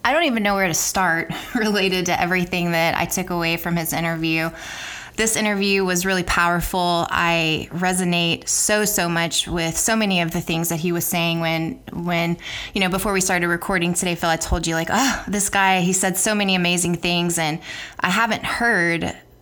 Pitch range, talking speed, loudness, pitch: 170-195 Hz, 200 wpm, -20 LUFS, 175 Hz